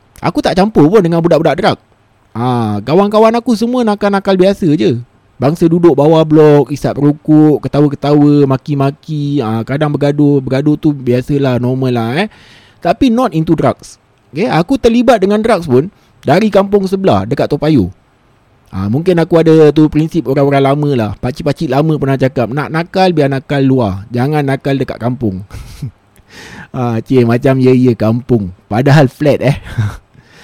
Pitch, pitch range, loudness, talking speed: 140 Hz, 120-160 Hz, -11 LUFS, 155 wpm